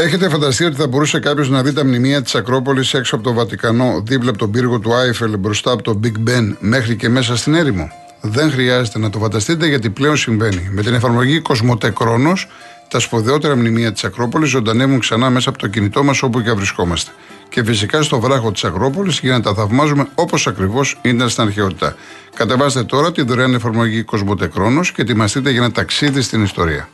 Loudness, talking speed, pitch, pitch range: -15 LUFS, 195 wpm, 125 Hz, 115-140 Hz